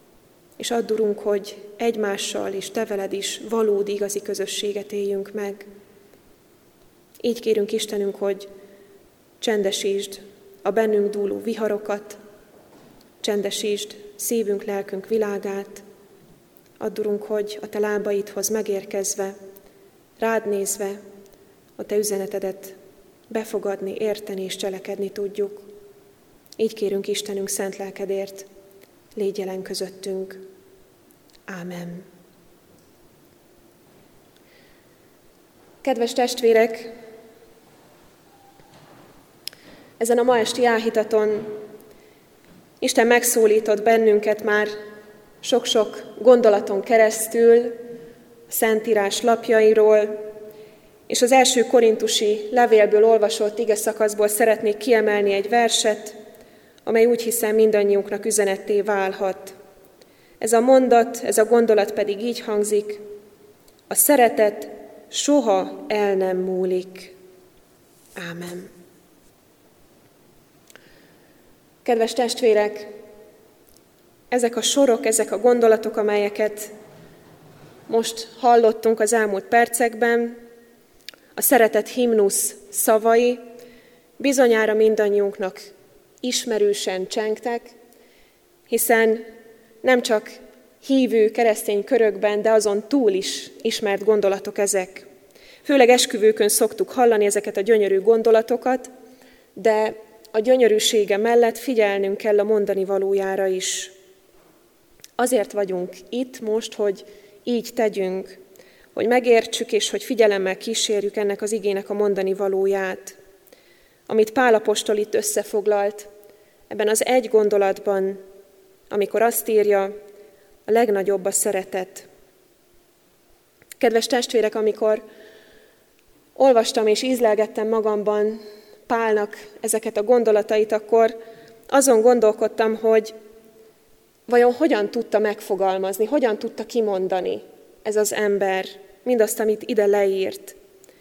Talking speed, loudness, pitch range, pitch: 95 wpm, -20 LUFS, 200-230 Hz, 215 Hz